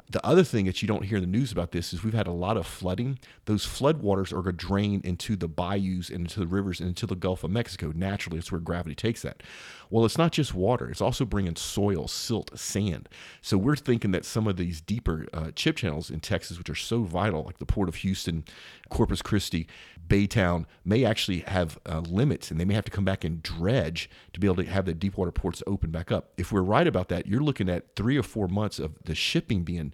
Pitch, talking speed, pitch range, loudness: 95 Hz, 245 wpm, 85-105 Hz, -28 LUFS